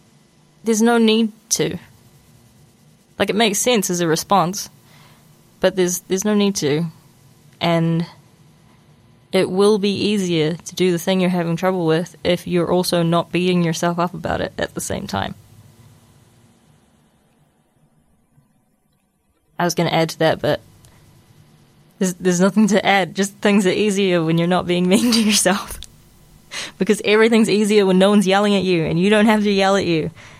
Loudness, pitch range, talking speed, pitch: -18 LUFS, 165-200 Hz, 165 wpm, 180 Hz